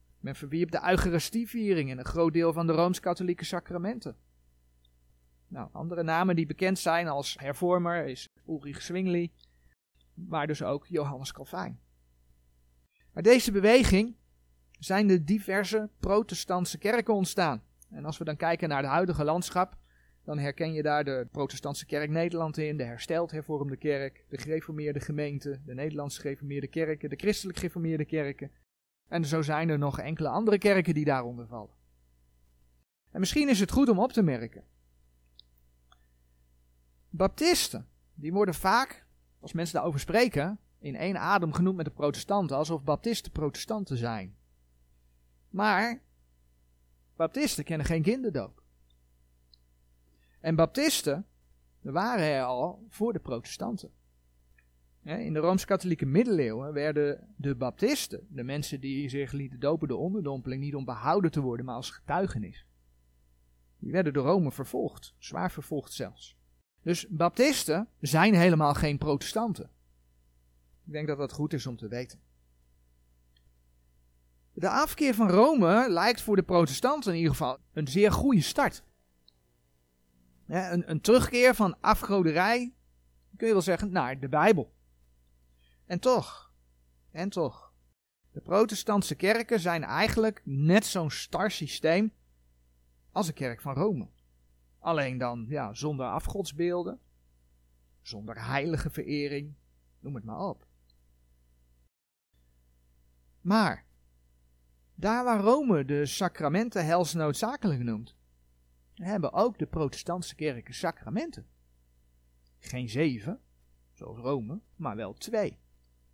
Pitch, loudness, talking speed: 145 Hz, -29 LUFS, 125 wpm